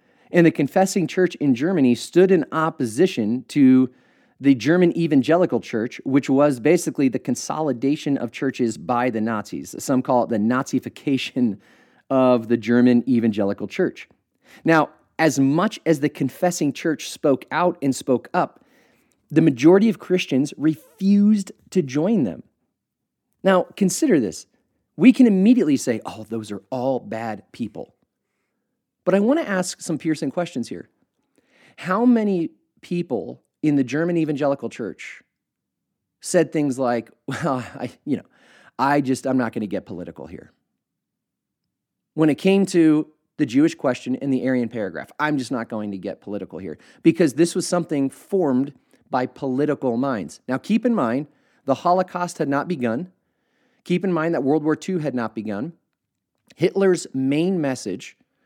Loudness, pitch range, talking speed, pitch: -21 LUFS, 130-180 Hz, 155 wpm, 150 Hz